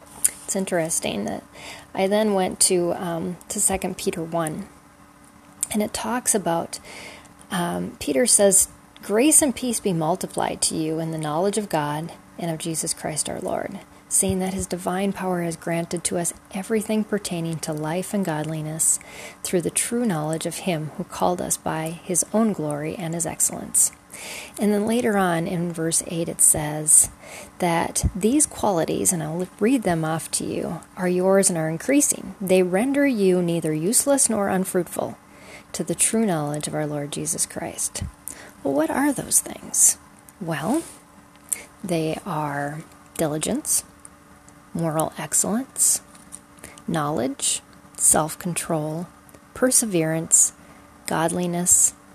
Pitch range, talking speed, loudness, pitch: 160-200 Hz, 145 wpm, -22 LUFS, 175 Hz